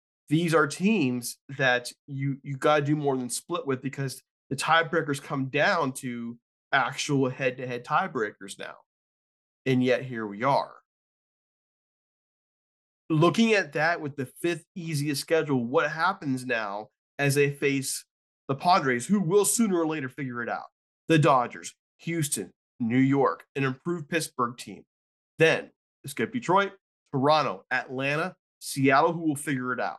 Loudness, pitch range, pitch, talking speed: -26 LUFS, 130-165 Hz, 140 Hz, 145 wpm